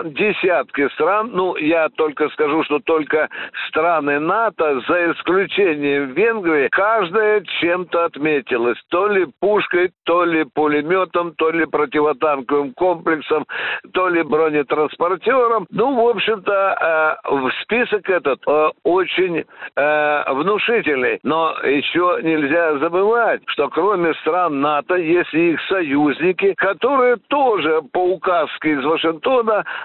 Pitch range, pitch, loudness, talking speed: 150-205 Hz, 170 Hz, -17 LUFS, 115 wpm